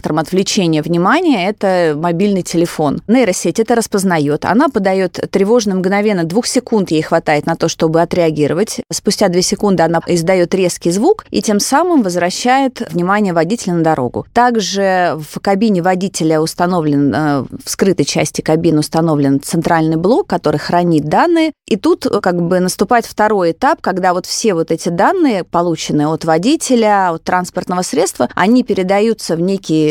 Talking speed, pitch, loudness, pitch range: 145 wpm, 180 Hz, -14 LUFS, 165-210 Hz